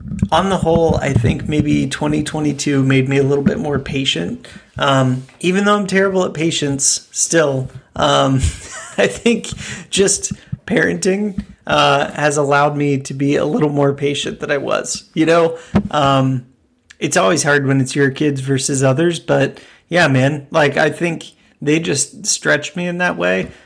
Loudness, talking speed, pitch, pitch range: -16 LUFS, 165 wpm, 145 Hz, 135-170 Hz